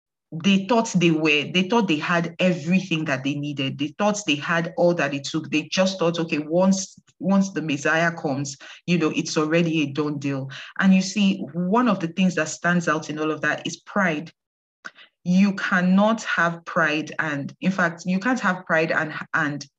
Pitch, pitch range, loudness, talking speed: 165 Hz, 155-185 Hz, -22 LUFS, 195 wpm